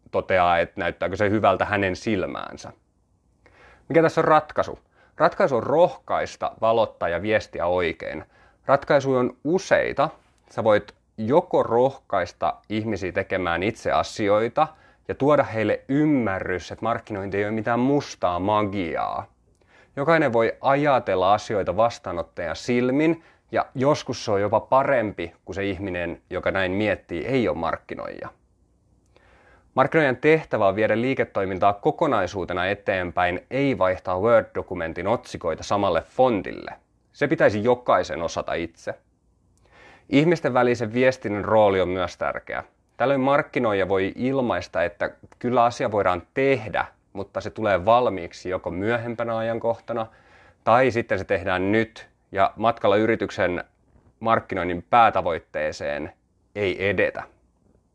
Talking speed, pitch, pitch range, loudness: 120 wpm, 110 Hz, 95-125 Hz, -23 LUFS